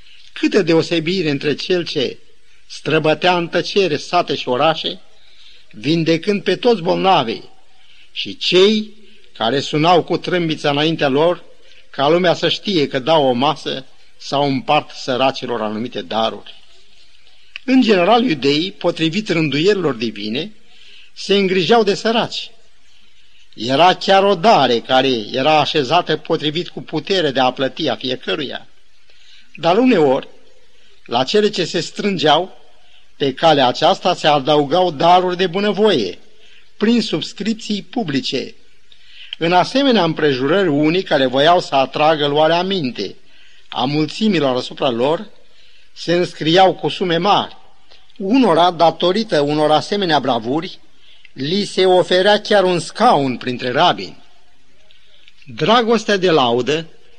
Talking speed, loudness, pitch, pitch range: 120 wpm, -16 LUFS, 170 Hz, 150-200 Hz